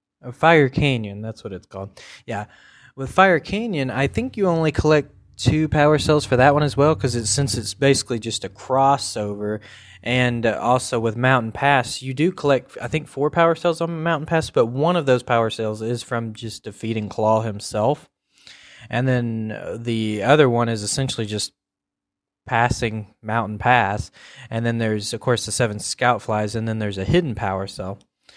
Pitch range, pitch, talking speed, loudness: 110-140 Hz, 120 Hz, 180 wpm, -20 LUFS